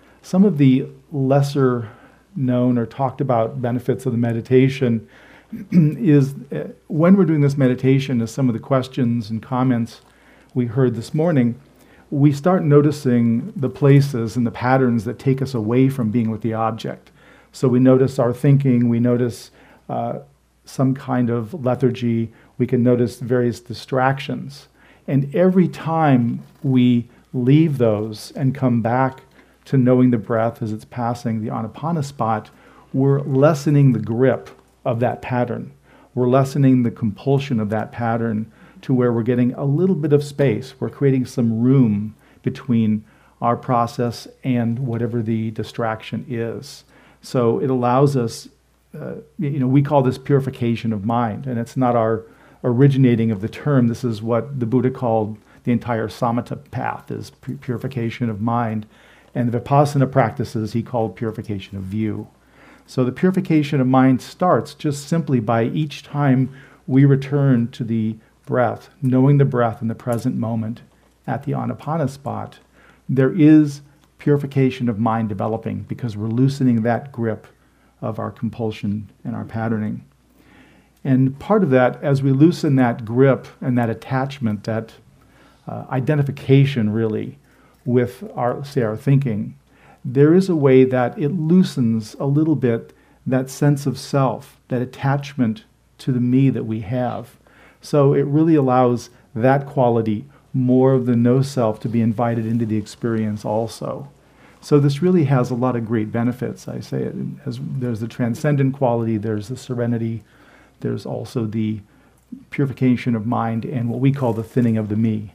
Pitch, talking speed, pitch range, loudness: 125 Hz, 155 wpm, 115-135 Hz, -19 LUFS